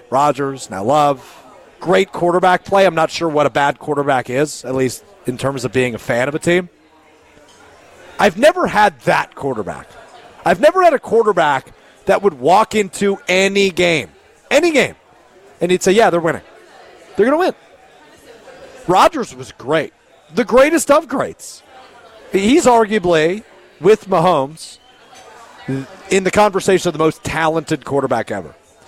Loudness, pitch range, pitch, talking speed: -15 LUFS, 145-200 Hz, 175 Hz, 150 wpm